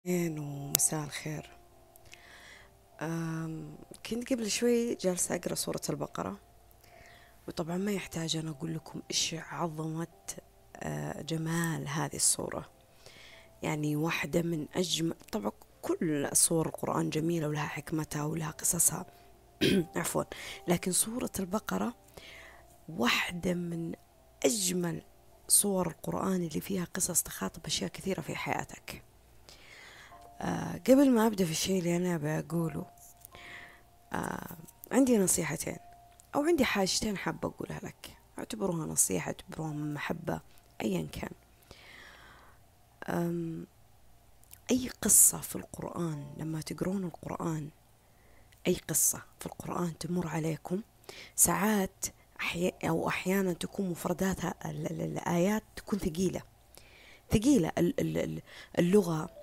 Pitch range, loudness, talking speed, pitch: 155-185 Hz, -31 LUFS, 100 wpm, 170 Hz